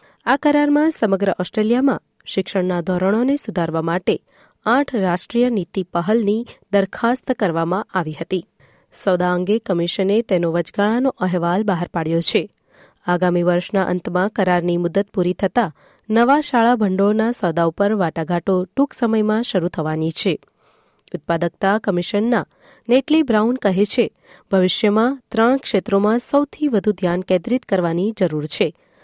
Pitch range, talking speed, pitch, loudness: 180-230 Hz, 120 wpm, 195 Hz, -19 LUFS